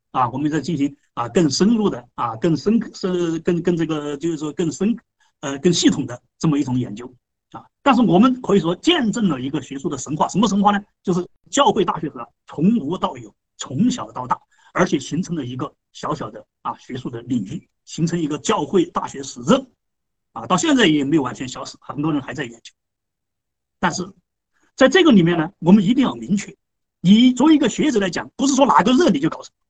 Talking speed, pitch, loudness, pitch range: 305 characters per minute, 175 Hz, -19 LUFS, 150-210 Hz